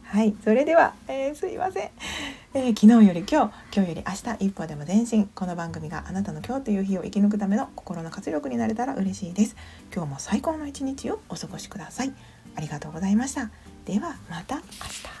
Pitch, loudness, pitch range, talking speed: 210 Hz, -25 LUFS, 185-255 Hz, 410 characters per minute